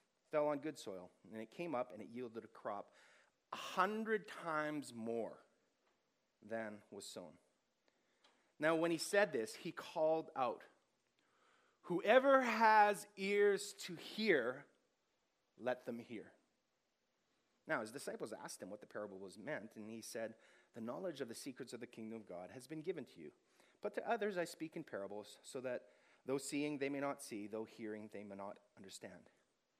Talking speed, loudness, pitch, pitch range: 170 wpm, -41 LUFS, 140 Hz, 110-170 Hz